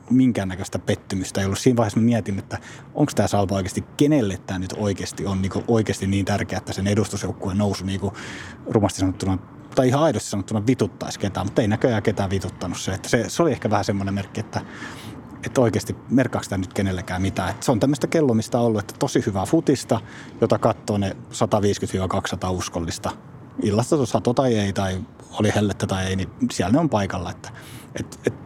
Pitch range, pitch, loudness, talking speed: 95-120 Hz, 105 Hz, -23 LUFS, 185 wpm